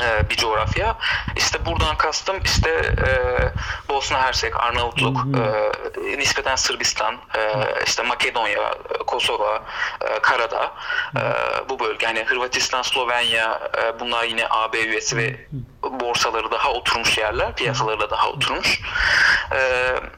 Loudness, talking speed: -20 LUFS, 120 wpm